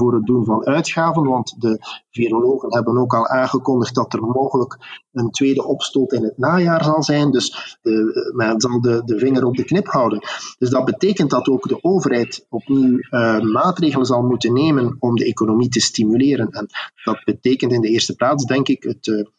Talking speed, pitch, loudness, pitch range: 195 wpm, 125 Hz, -17 LUFS, 115-135 Hz